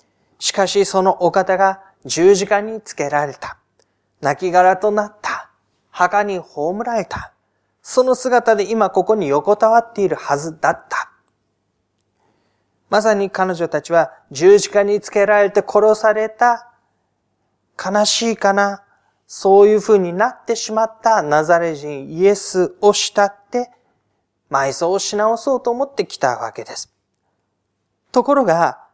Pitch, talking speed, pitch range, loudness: 200 Hz, 250 characters per minute, 170-220 Hz, -16 LUFS